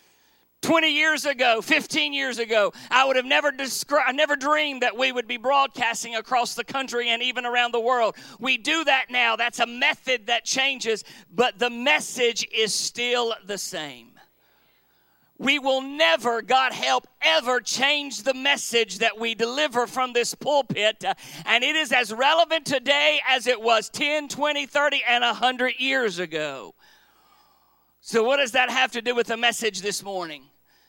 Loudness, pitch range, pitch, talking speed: -22 LUFS, 230-285 Hz, 255 Hz, 165 wpm